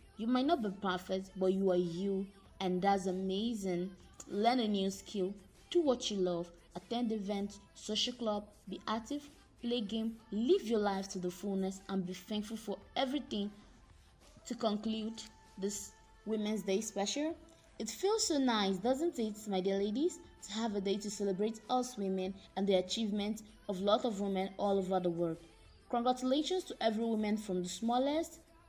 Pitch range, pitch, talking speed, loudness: 195-235 Hz, 210 Hz, 165 wpm, -36 LUFS